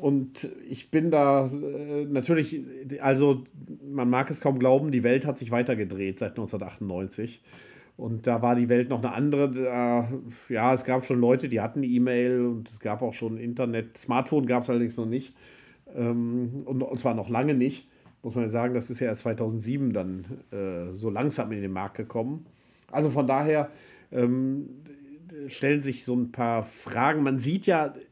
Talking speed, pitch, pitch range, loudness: 180 wpm, 125 Hz, 120-140 Hz, -27 LUFS